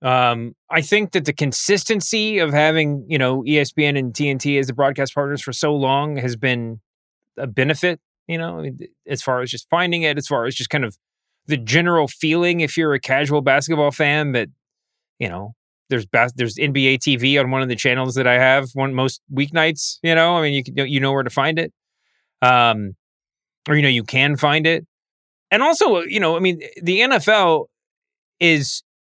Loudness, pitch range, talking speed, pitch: -18 LUFS, 130-165 Hz, 195 wpm, 145 Hz